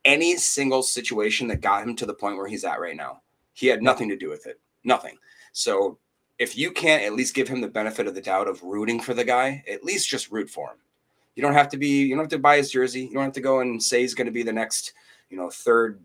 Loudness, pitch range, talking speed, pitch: -23 LUFS, 120-145 Hz, 275 wpm, 130 Hz